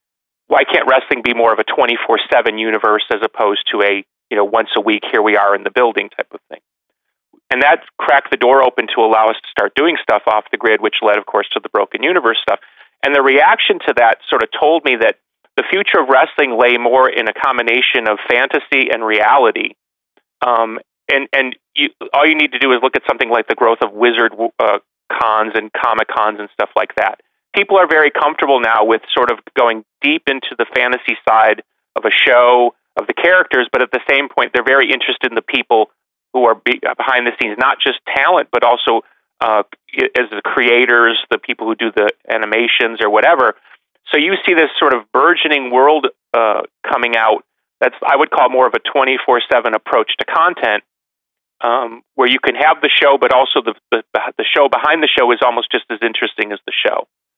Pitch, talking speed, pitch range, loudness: 120 Hz, 215 wpm, 110-135 Hz, -13 LUFS